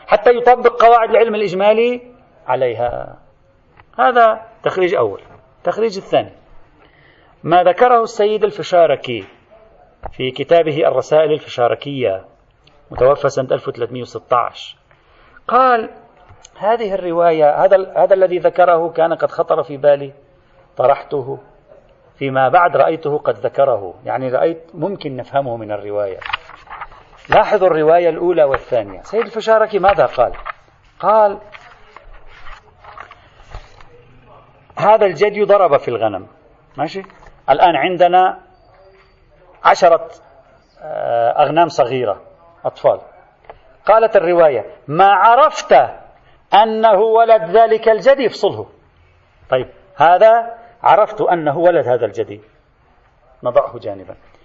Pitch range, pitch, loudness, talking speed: 145-220 Hz, 180 Hz, -14 LUFS, 95 wpm